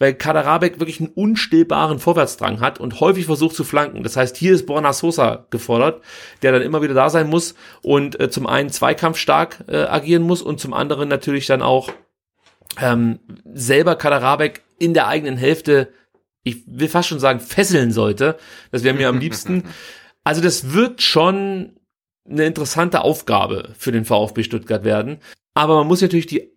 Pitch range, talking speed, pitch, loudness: 130-170 Hz, 170 wpm, 155 Hz, -17 LUFS